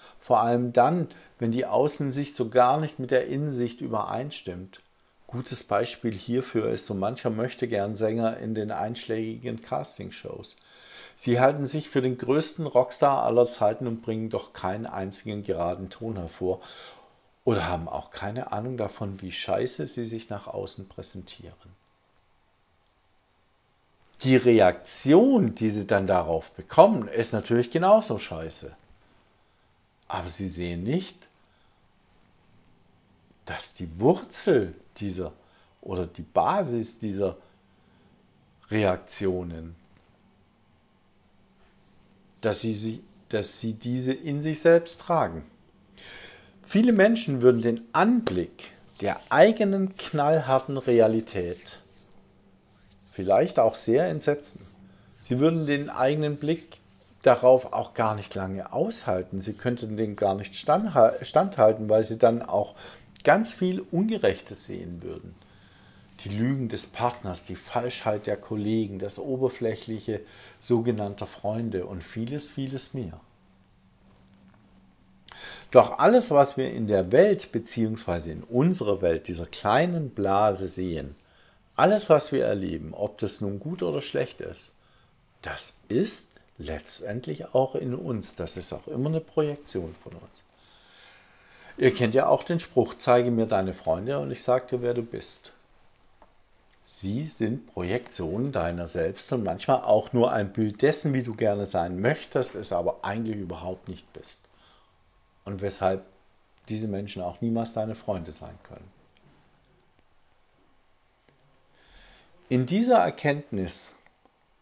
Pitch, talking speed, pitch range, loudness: 110 Hz, 125 wpm, 95-125 Hz, -26 LUFS